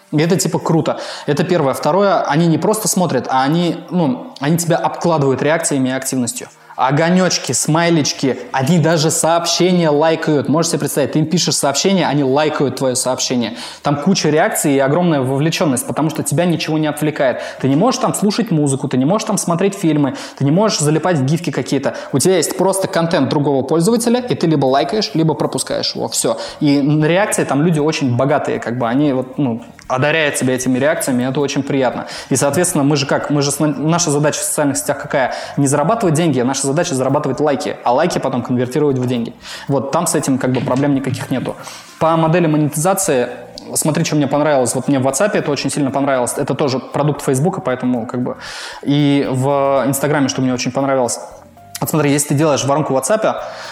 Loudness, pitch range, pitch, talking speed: -16 LUFS, 135-165 Hz, 145 Hz, 195 wpm